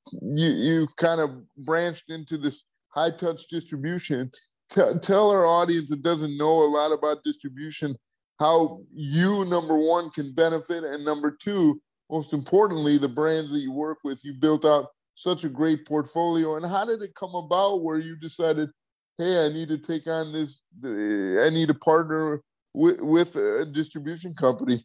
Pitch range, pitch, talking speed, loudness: 150-170 Hz, 160 Hz, 165 wpm, -24 LUFS